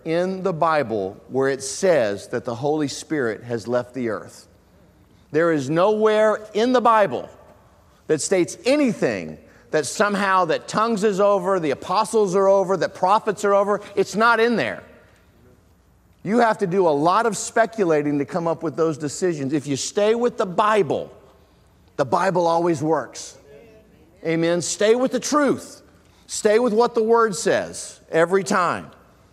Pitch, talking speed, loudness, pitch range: 185 Hz, 160 wpm, -20 LUFS, 150-215 Hz